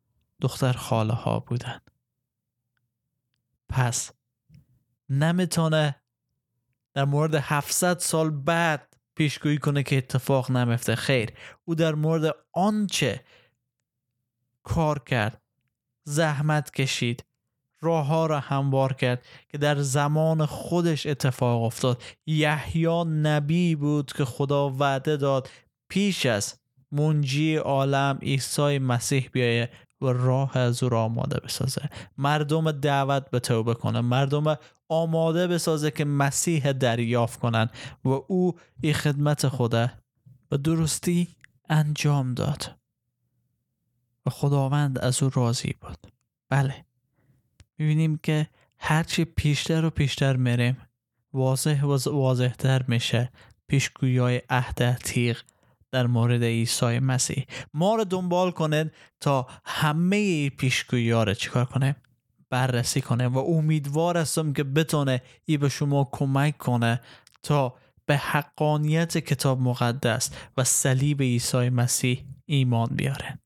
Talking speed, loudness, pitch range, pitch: 110 wpm, -25 LUFS, 125-150 Hz, 135 Hz